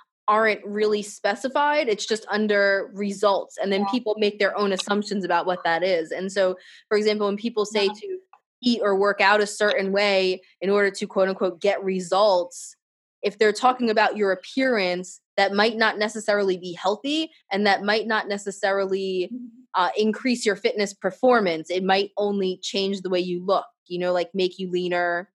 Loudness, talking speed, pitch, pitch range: -23 LUFS, 180 wpm, 200 Hz, 190-215 Hz